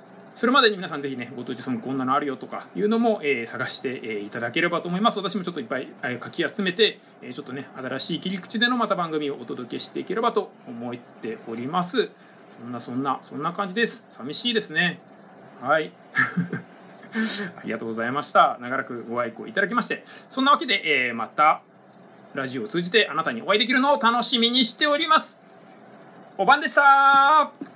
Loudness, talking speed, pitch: -22 LUFS, 395 characters per minute, 195 Hz